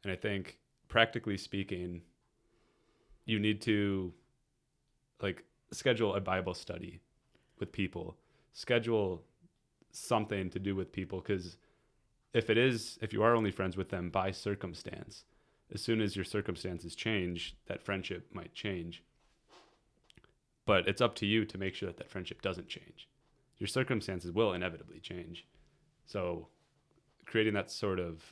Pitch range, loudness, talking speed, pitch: 90-115 Hz, -35 LUFS, 140 wpm, 100 Hz